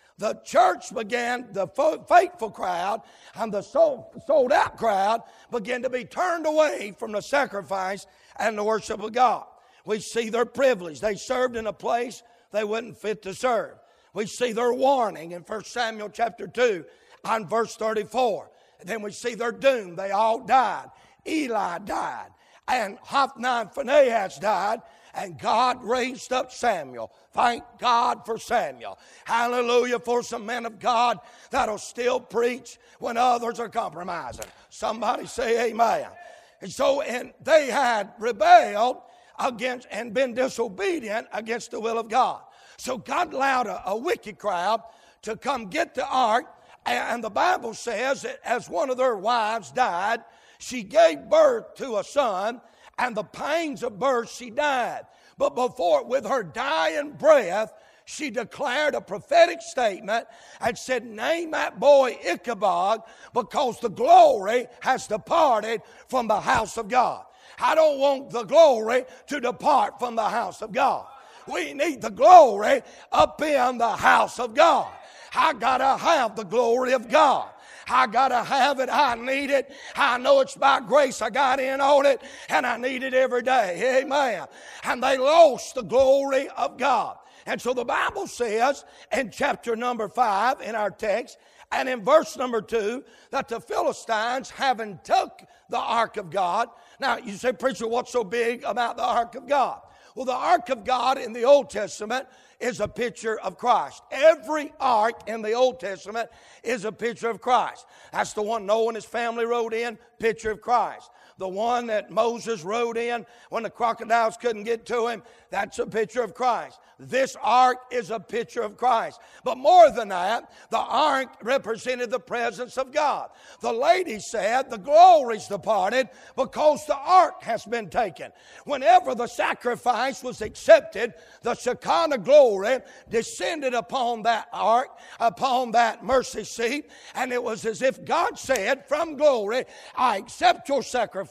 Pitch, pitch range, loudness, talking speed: 245 Hz, 225-275 Hz, -24 LUFS, 165 wpm